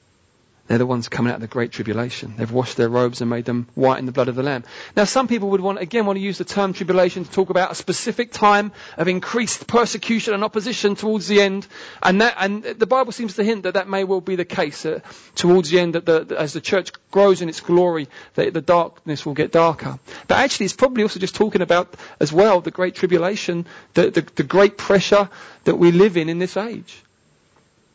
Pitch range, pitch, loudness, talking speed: 160-205 Hz, 185 Hz, -19 LUFS, 235 wpm